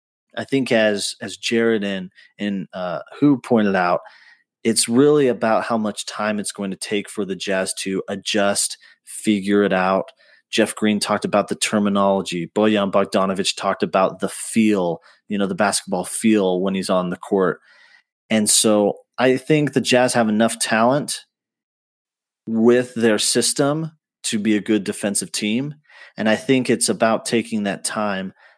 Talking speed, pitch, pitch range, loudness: 160 wpm, 105 Hz, 100-115 Hz, -19 LUFS